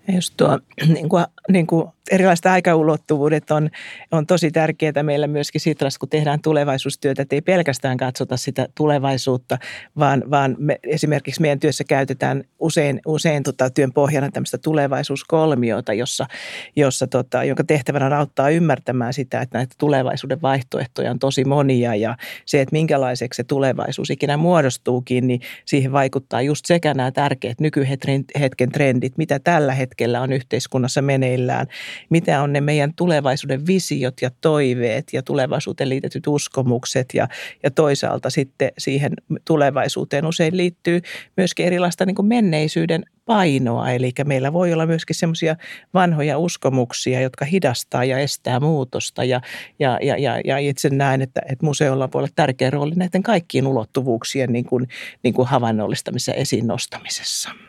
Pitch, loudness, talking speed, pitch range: 140 Hz, -19 LUFS, 140 wpm, 130-155 Hz